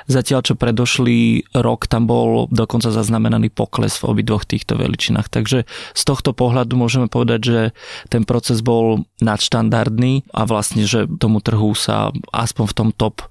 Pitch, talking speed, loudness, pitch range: 115 Hz, 155 wpm, -17 LUFS, 110-125 Hz